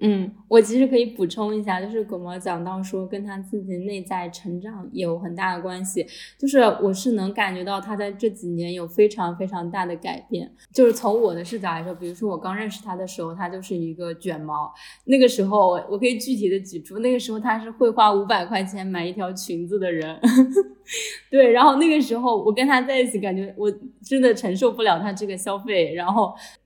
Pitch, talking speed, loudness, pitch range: 200 Hz, 315 characters per minute, -22 LUFS, 180-230 Hz